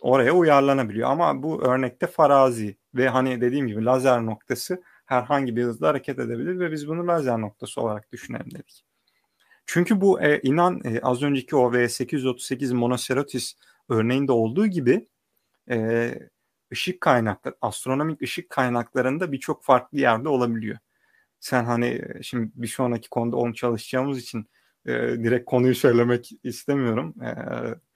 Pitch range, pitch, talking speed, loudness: 120-140 Hz, 125 Hz, 135 wpm, -23 LUFS